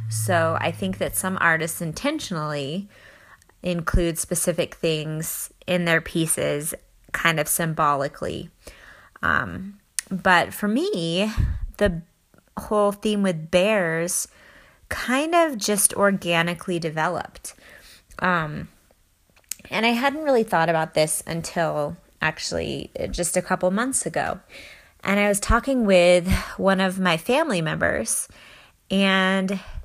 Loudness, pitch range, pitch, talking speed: -23 LUFS, 165-200 Hz, 180 Hz, 115 wpm